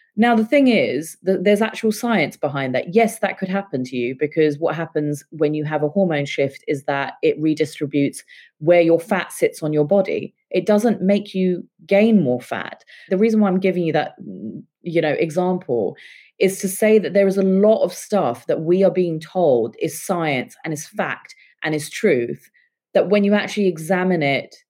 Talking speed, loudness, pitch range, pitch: 200 wpm, -19 LUFS, 155-205 Hz, 180 Hz